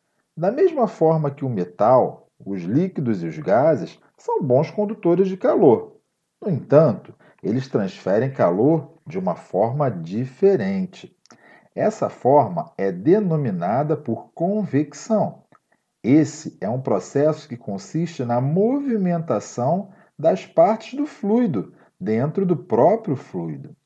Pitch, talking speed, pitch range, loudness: 165 Hz, 120 wpm, 140-210 Hz, -21 LUFS